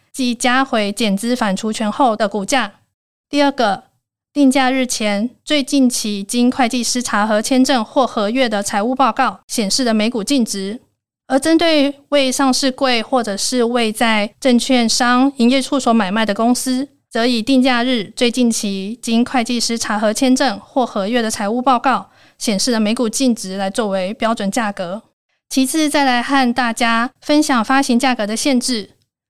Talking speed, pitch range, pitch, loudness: 250 characters per minute, 220-265 Hz, 245 Hz, -16 LUFS